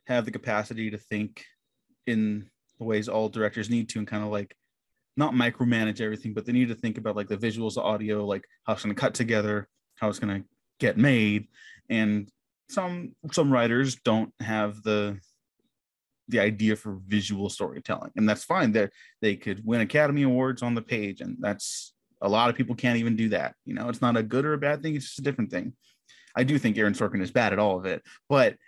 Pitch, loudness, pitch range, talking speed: 110 Hz, -27 LUFS, 105-120 Hz, 215 wpm